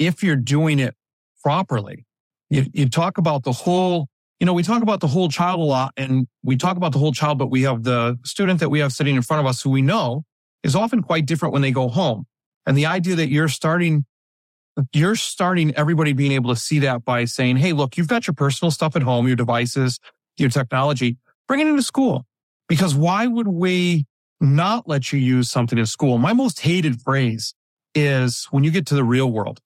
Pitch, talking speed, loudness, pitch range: 145 Hz, 220 wpm, -20 LUFS, 130-170 Hz